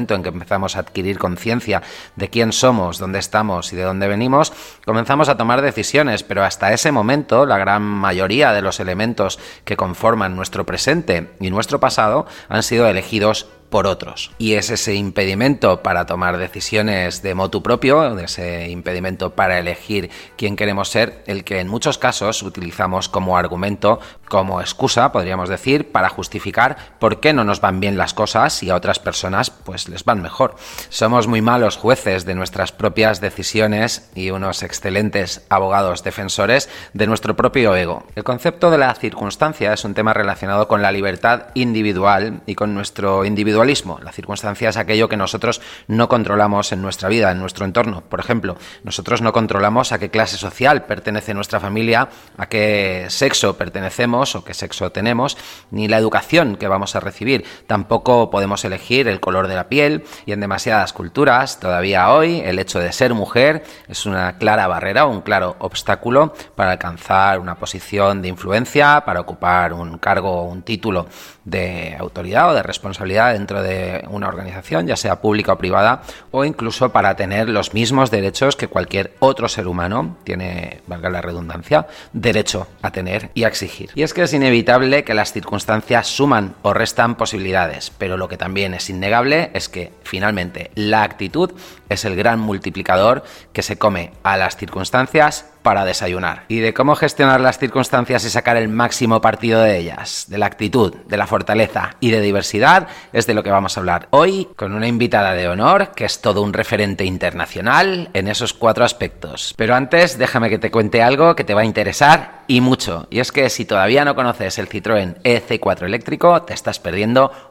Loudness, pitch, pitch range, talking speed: -17 LUFS, 105 Hz, 95-115 Hz, 175 wpm